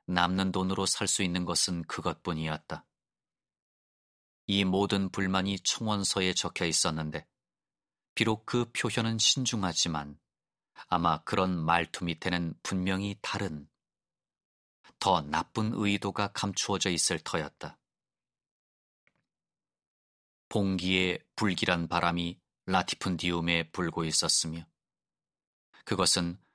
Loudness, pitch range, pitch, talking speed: -29 LUFS, 85-100 Hz, 90 Hz, 220 characters per minute